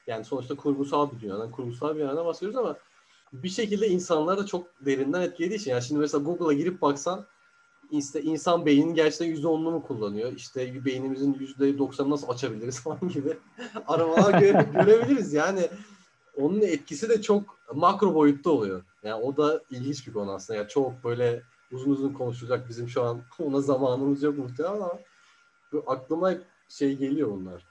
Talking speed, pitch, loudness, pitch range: 165 wpm, 150 Hz, -27 LUFS, 135-180 Hz